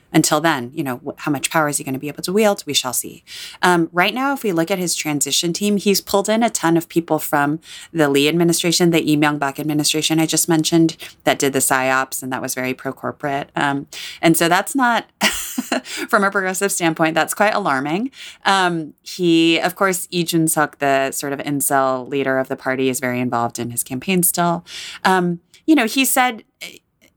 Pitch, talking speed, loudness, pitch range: 160 Hz, 210 wpm, -18 LUFS, 140-185 Hz